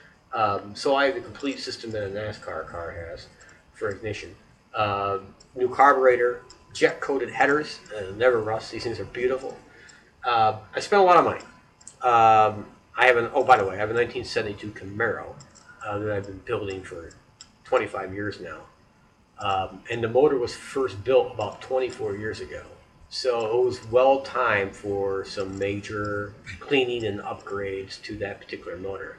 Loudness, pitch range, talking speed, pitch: -24 LUFS, 100-140 Hz, 170 wpm, 110 Hz